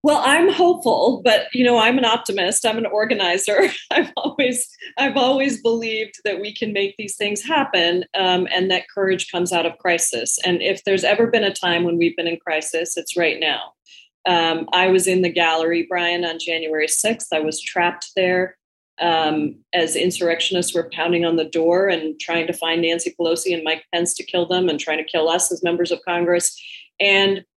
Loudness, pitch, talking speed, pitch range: -19 LUFS, 180 Hz, 200 wpm, 170-210 Hz